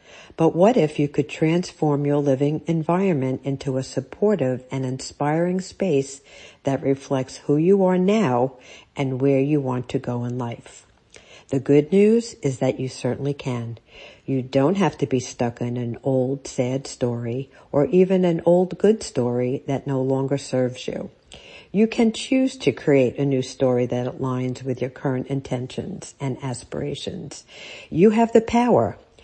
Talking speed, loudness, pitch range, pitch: 160 wpm, -22 LUFS, 130-165 Hz, 135 Hz